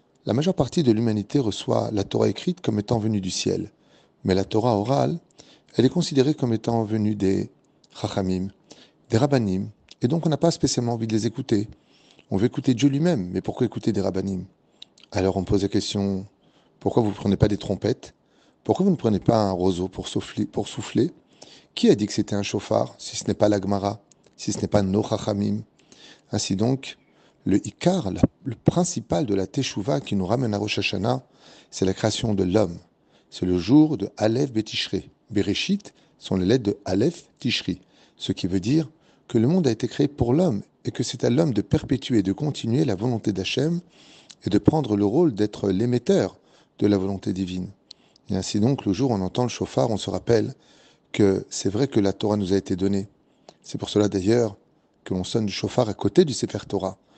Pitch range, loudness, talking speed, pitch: 100-125 Hz, -24 LUFS, 205 wpm, 105 Hz